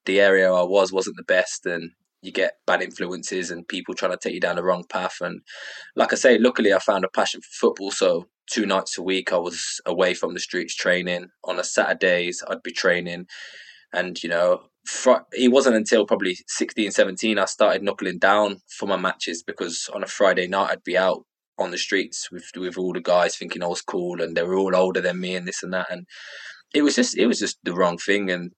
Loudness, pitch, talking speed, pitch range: -22 LUFS, 90 Hz, 235 wpm, 90-95 Hz